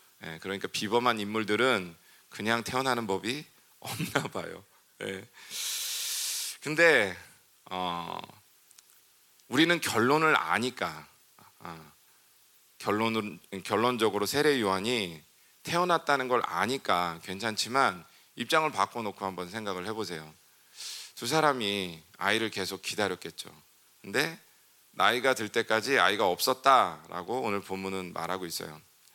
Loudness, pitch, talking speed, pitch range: -29 LUFS, 105 Hz, 255 characters per minute, 95-120 Hz